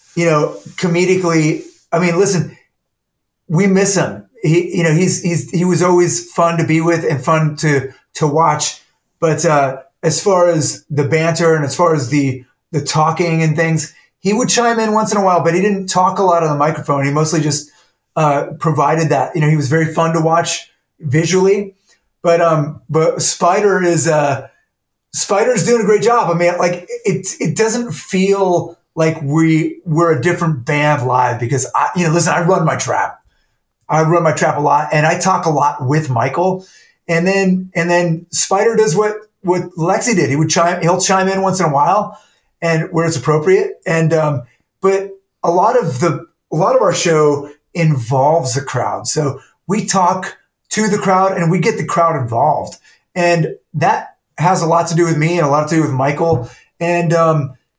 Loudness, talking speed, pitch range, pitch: -15 LUFS, 195 wpm, 155-180 Hz, 165 Hz